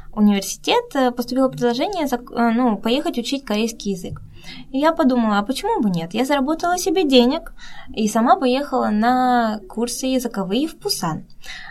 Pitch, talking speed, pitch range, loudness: 250 Hz, 140 wpm, 225-285 Hz, -19 LUFS